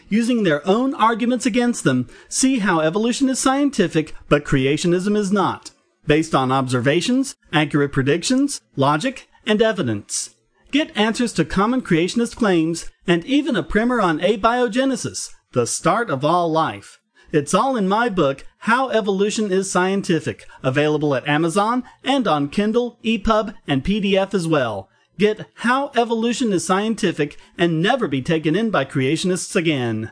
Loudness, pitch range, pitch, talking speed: -19 LUFS, 150-235 Hz, 190 Hz, 145 wpm